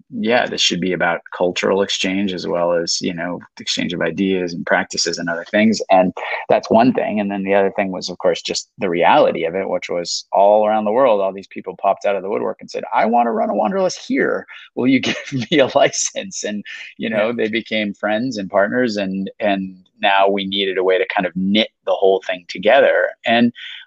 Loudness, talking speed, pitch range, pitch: -18 LUFS, 230 wpm, 95-110 Hz, 100 Hz